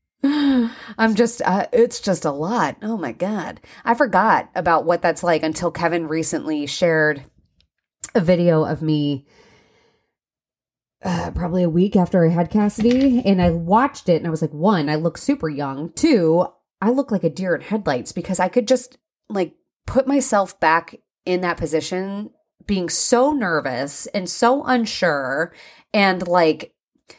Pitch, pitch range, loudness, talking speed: 185 Hz, 165-235 Hz, -19 LUFS, 160 wpm